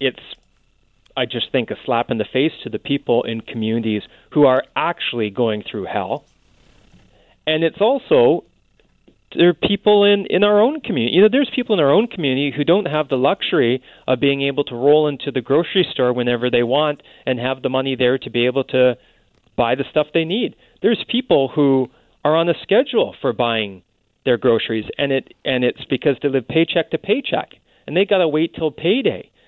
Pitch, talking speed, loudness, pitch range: 140 Hz, 200 wpm, -18 LUFS, 125-170 Hz